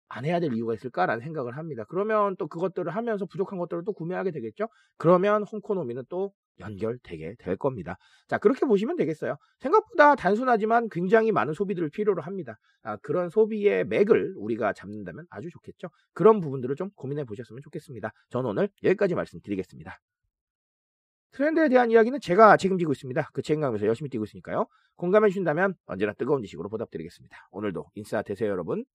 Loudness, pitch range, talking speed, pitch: -26 LUFS, 140-215 Hz, 460 characters per minute, 185 Hz